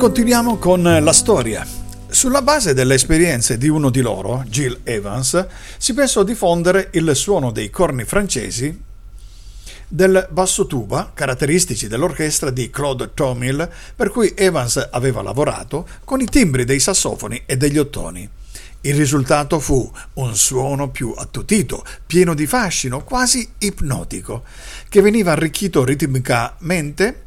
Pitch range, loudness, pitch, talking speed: 125-185 Hz, -17 LUFS, 145 Hz, 130 wpm